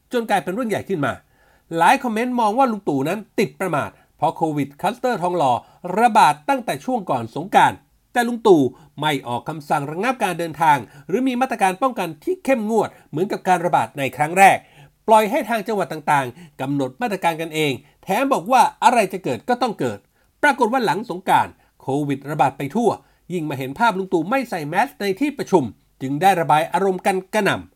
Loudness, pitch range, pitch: -20 LUFS, 150-240 Hz, 185 Hz